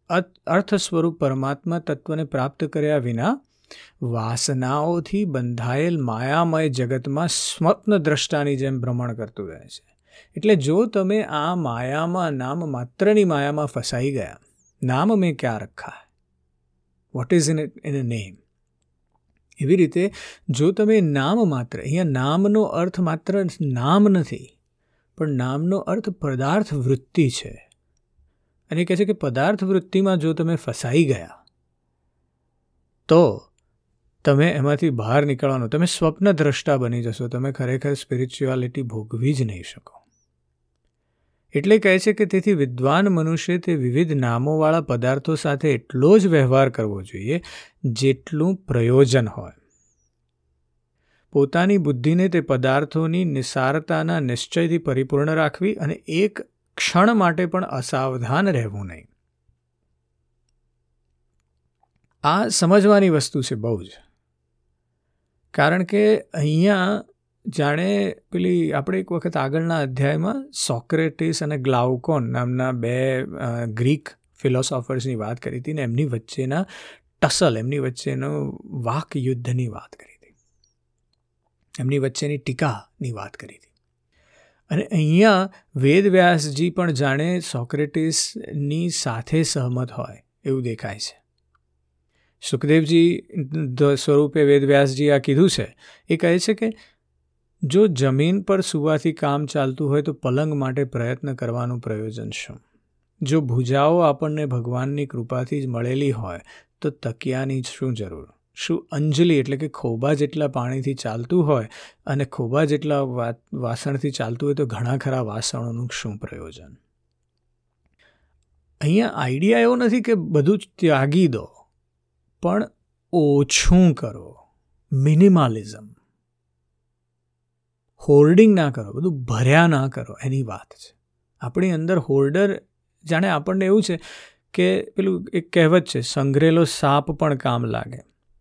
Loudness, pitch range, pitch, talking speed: -21 LUFS, 115-165 Hz, 140 Hz, 120 wpm